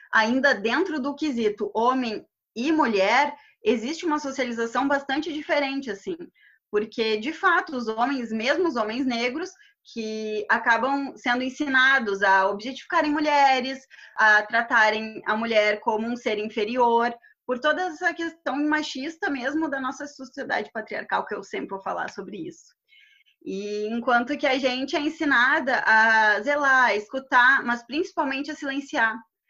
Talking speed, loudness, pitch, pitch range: 140 wpm, -23 LUFS, 265 Hz, 225-305 Hz